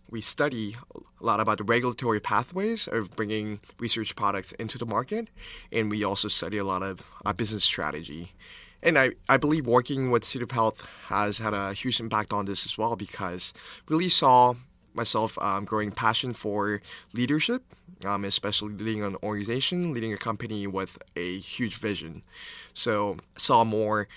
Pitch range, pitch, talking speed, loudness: 100-120 Hz, 110 Hz, 170 wpm, -27 LUFS